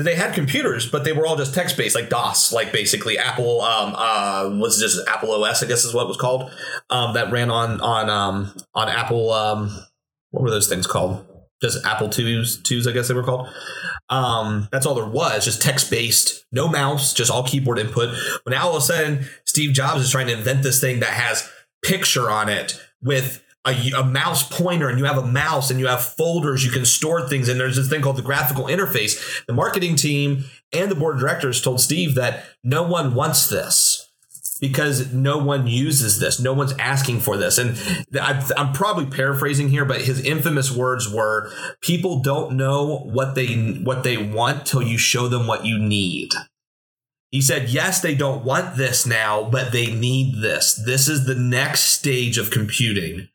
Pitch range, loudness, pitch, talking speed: 120-140 Hz, -19 LUFS, 130 Hz, 200 wpm